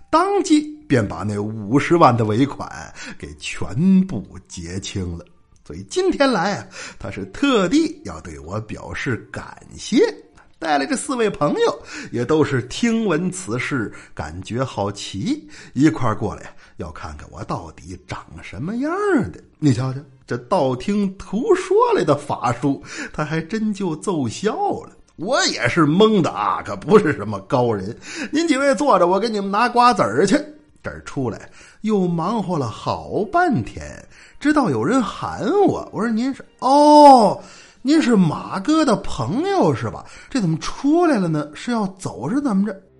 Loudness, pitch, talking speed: -19 LUFS, 195 Hz, 225 characters per minute